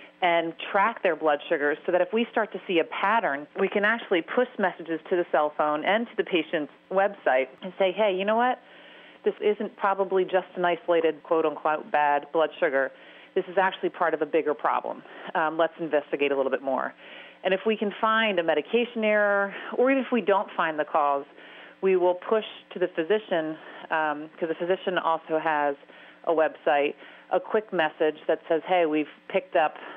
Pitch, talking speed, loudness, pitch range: 175 Hz, 200 wpm, -26 LUFS, 155-200 Hz